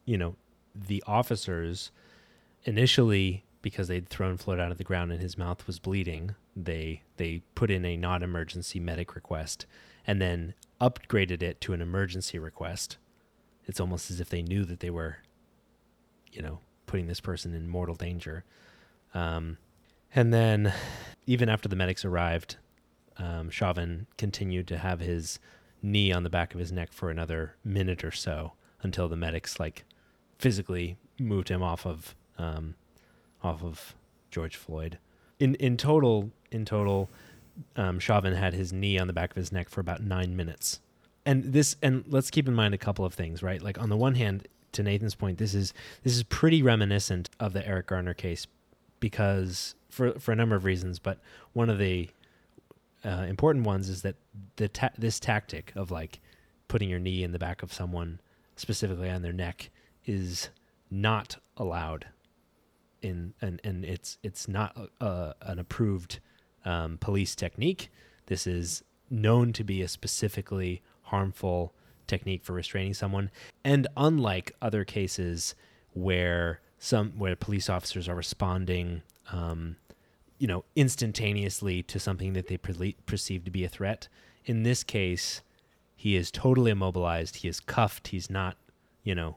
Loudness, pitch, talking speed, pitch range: -31 LUFS, 95 Hz, 165 wpm, 85-105 Hz